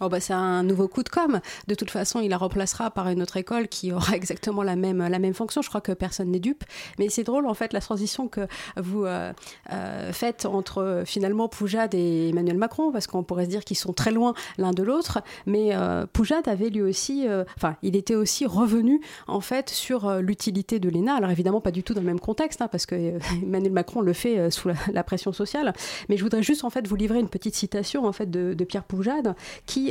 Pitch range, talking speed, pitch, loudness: 185-230 Hz, 245 wpm, 200 Hz, -26 LUFS